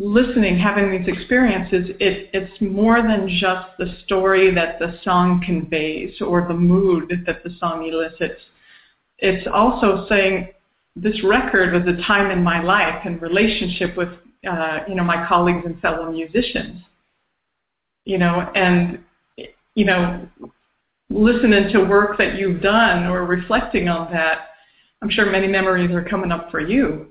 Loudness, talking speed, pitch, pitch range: -18 LUFS, 150 wpm, 185 Hz, 175-200 Hz